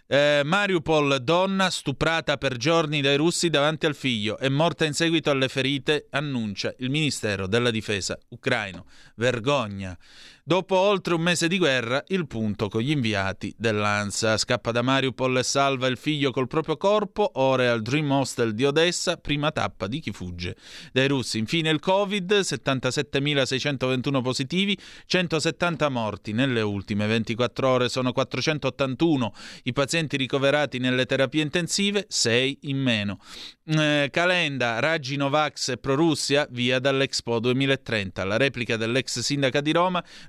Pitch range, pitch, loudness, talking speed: 120-155 Hz, 135 Hz, -24 LUFS, 145 wpm